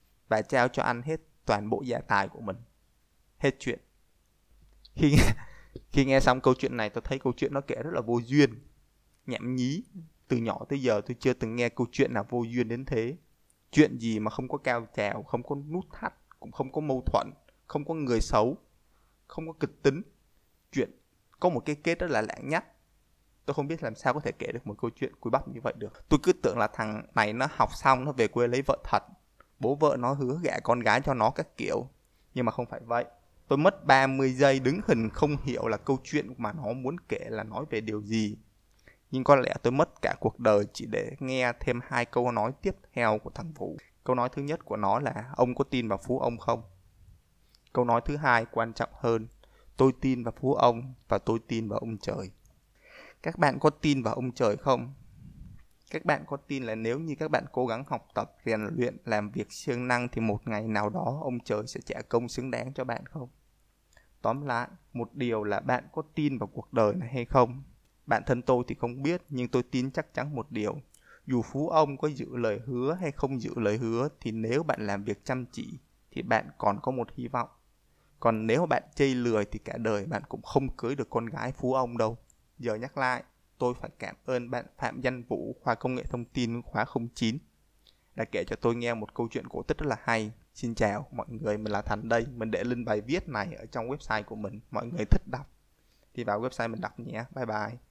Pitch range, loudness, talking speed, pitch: 110-135 Hz, -30 LUFS, 230 wpm, 125 Hz